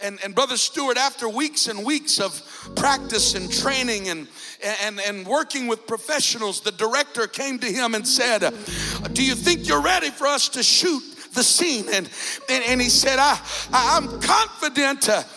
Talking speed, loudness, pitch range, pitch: 175 wpm, -20 LUFS, 215-280 Hz, 255 Hz